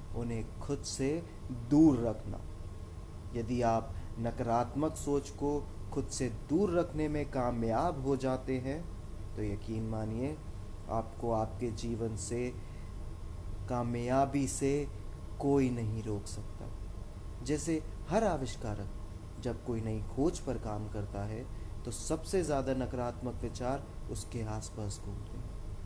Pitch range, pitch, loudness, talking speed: 100-130 Hz, 115 Hz, -35 LUFS, 120 wpm